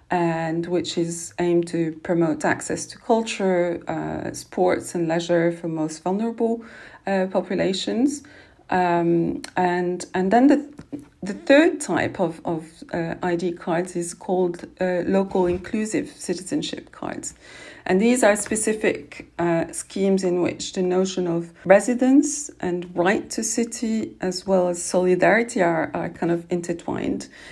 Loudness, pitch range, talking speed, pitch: -22 LUFS, 170-210 Hz, 135 wpm, 180 Hz